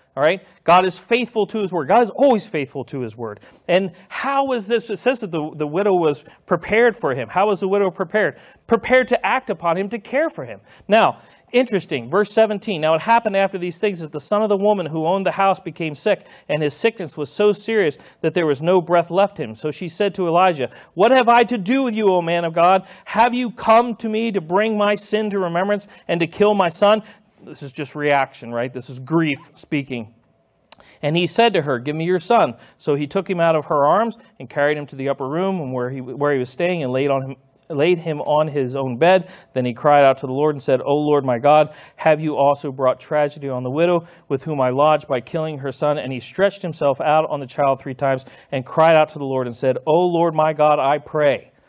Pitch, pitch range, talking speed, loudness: 165 Hz, 145-205 Hz, 250 wpm, -19 LUFS